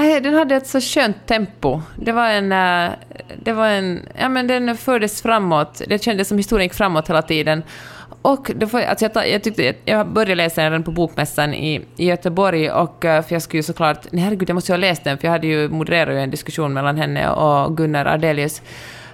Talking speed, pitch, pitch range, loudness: 200 wpm, 175 Hz, 155-220 Hz, -18 LUFS